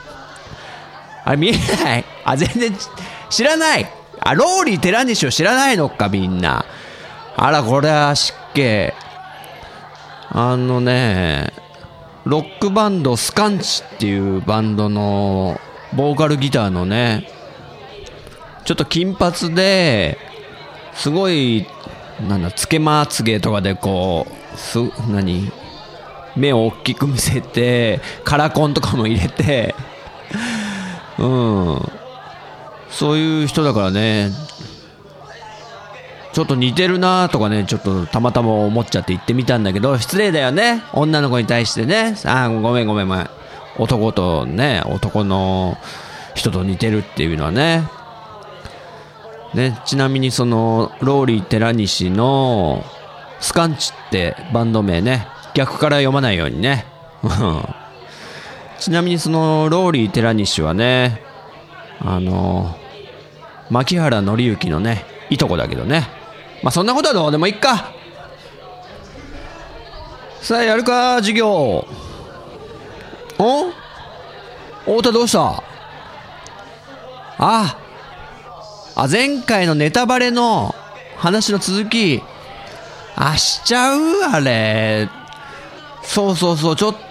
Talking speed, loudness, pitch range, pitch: 225 characters per minute, -17 LUFS, 110-175 Hz, 130 Hz